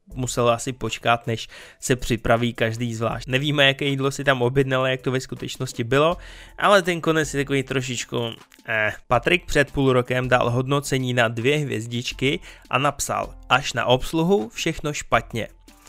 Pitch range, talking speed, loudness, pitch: 120-140 Hz, 160 wpm, -22 LUFS, 130 Hz